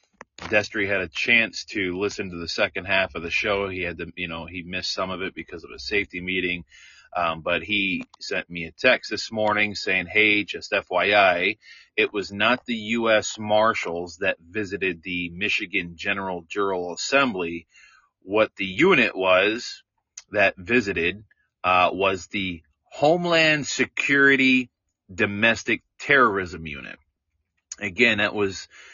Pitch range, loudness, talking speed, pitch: 85-105 Hz, -22 LUFS, 145 wpm, 95 Hz